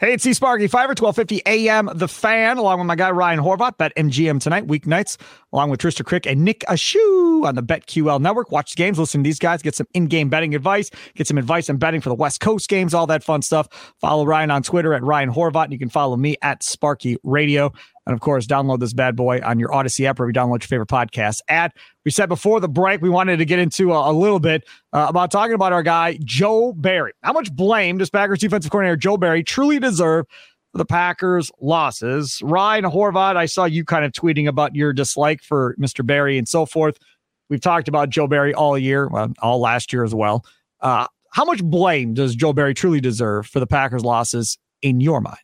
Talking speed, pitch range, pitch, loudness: 230 wpm, 140-185 Hz, 160 Hz, -18 LUFS